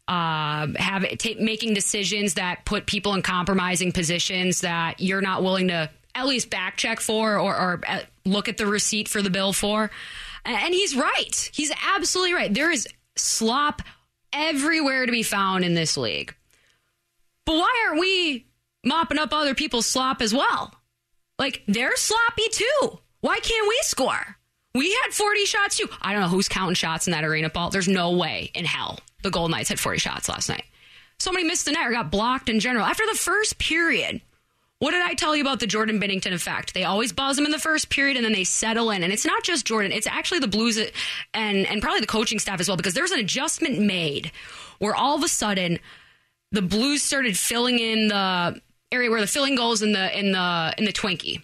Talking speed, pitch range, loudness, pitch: 210 wpm, 190-290 Hz, -23 LUFS, 220 Hz